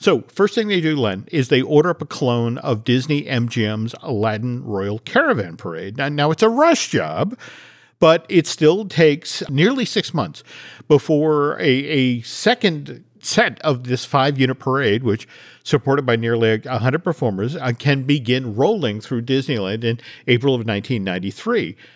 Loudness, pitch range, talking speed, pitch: -19 LUFS, 115-155 Hz, 155 wpm, 135 Hz